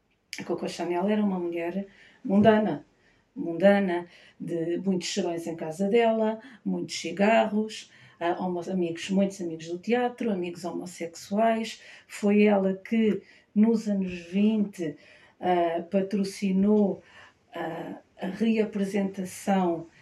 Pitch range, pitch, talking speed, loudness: 175-210 Hz, 195 Hz, 110 wpm, -27 LUFS